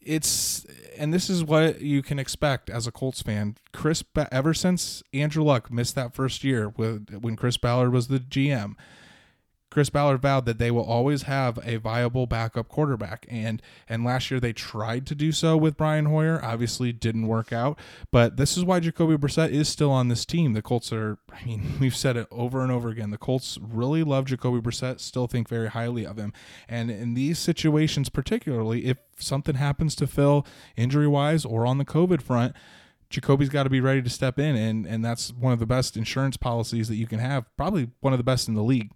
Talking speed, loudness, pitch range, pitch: 210 wpm, -25 LUFS, 115-145 Hz, 130 Hz